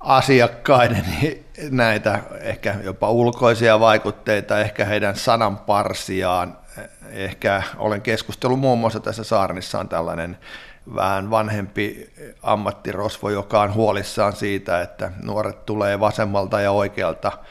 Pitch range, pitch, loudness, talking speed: 100-110 Hz, 105 Hz, -20 LUFS, 105 wpm